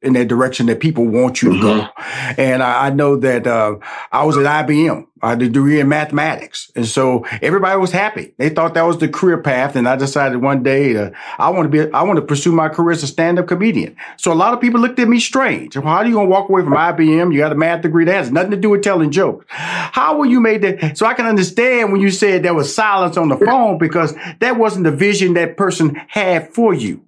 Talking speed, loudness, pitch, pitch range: 260 wpm, -14 LUFS, 165 Hz, 140-195 Hz